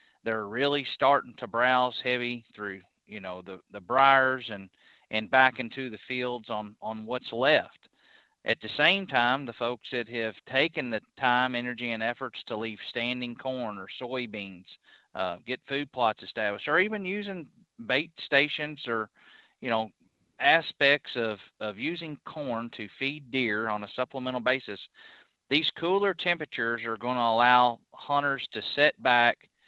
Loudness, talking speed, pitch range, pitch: -28 LUFS, 155 wpm, 115-140 Hz, 125 Hz